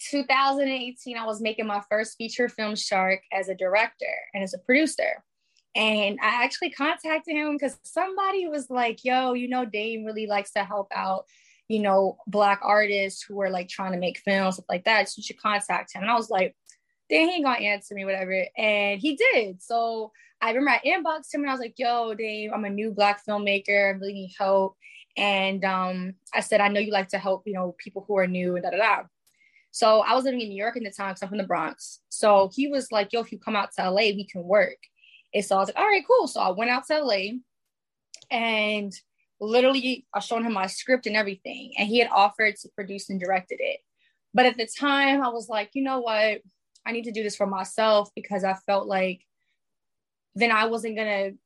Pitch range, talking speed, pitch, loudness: 200-255 Hz, 225 wpm, 215 Hz, -25 LUFS